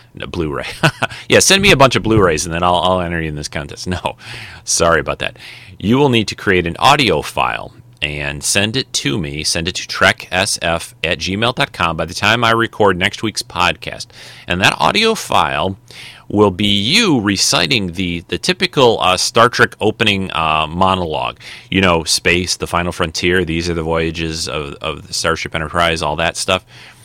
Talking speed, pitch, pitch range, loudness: 190 wpm, 95 Hz, 85-110 Hz, -15 LUFS